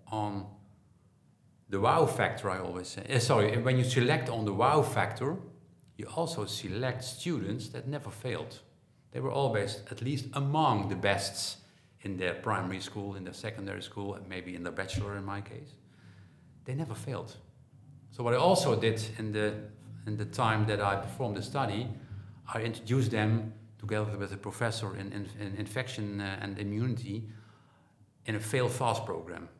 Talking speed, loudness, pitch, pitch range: 165 wpm, -32 LUFS, 110 Hz, 100-125 Hz